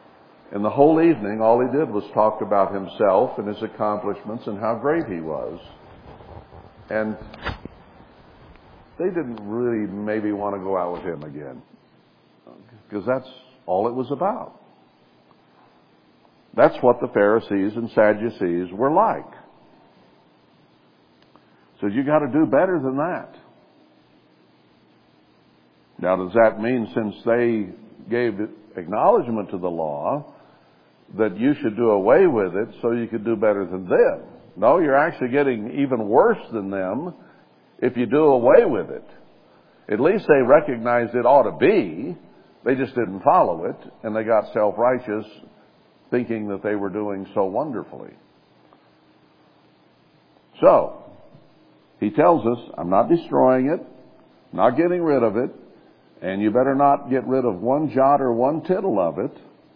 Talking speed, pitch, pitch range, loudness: 145 wpm, 110 Hz, 100-130 Hz, -21 LUFS